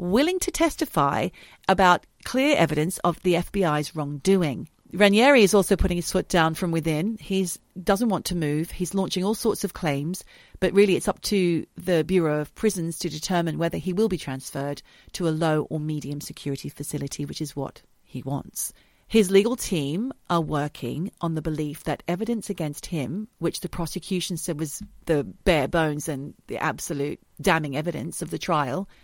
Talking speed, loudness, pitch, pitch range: 180 wpm, -25 LUFS, 175 Hz, 155-195 Hz